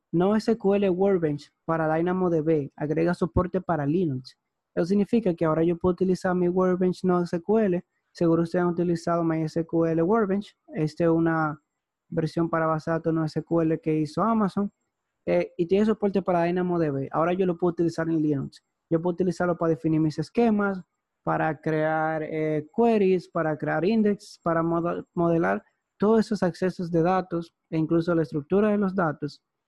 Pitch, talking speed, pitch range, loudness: 170 Hz, 160 wpm, 160-185 Hz, -25 LUFS